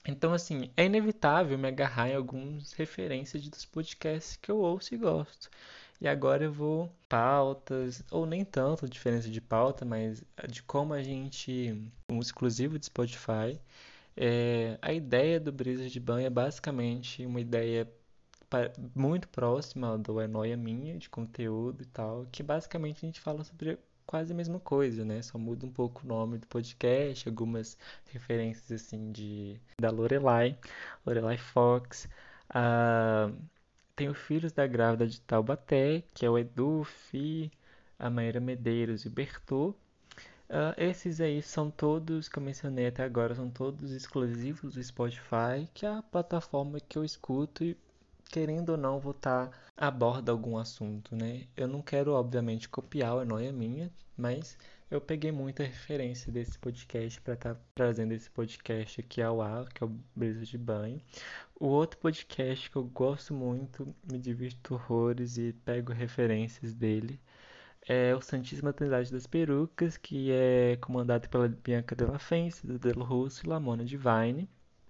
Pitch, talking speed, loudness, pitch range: 125 Hz, 160 wpm, -33 LUFS, 115-145 Hz